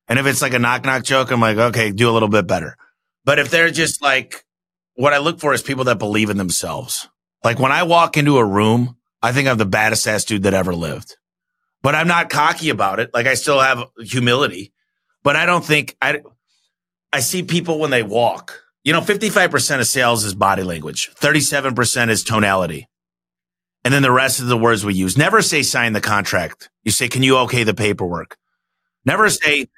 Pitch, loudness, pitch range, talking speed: 125 Hz, -16 LUFS, 105-145 Hz, 210 wpm